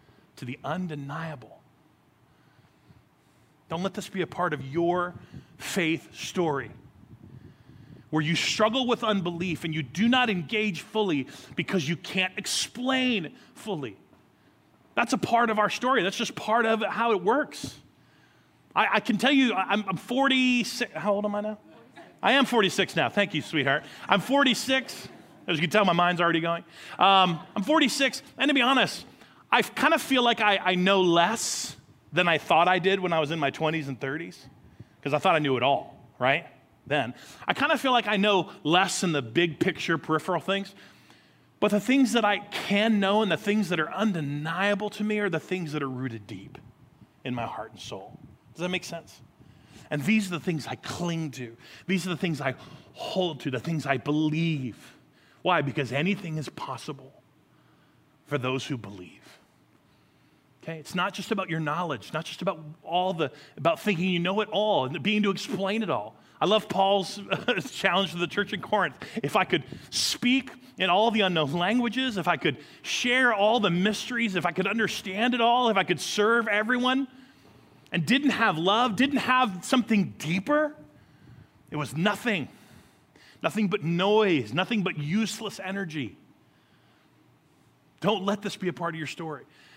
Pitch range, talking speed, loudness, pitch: 155-215 Hz, 180 wpm, -26 LUFS, 185 Hz